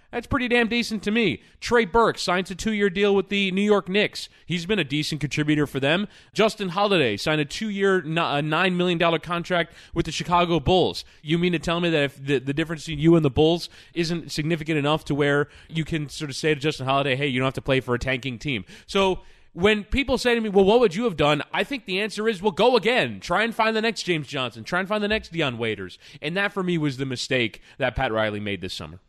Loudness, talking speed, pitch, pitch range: -23 LUFS, 255 wpm, 170 Hz, 145-200 Hz